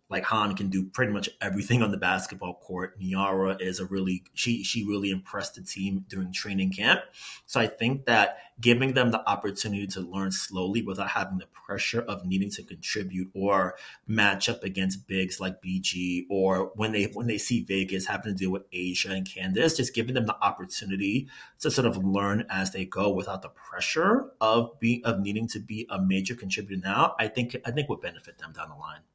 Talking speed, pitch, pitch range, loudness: 205 wpm, 100 Hz, 95-110 Hz, -28 LUFS